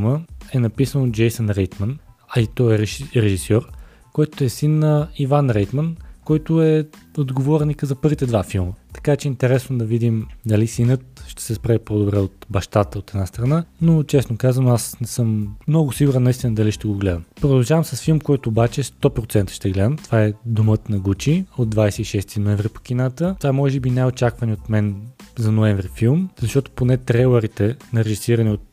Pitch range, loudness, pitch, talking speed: 105-140 Hz, -20 LUFS, 120 Hz, 185 wpm